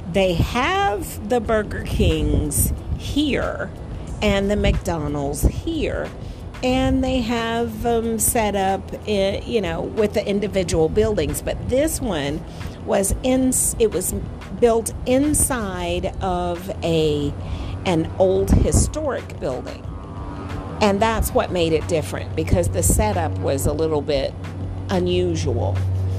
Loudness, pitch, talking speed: -21 LUFS, 175 Hz, 120 wpm